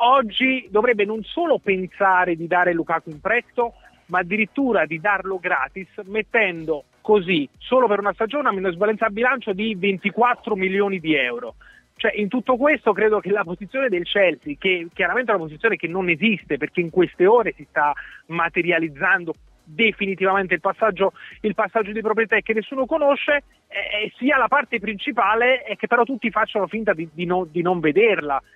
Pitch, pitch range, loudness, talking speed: 205 Hz, 180-230 Hz, -21 LUFS, 170 wpm